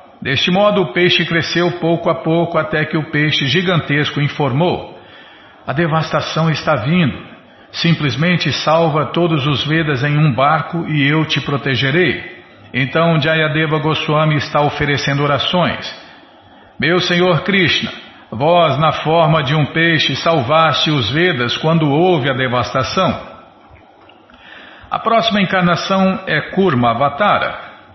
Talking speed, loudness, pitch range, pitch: 125 wpm, -15 LUFS, 145-170 Hz, 160 Hz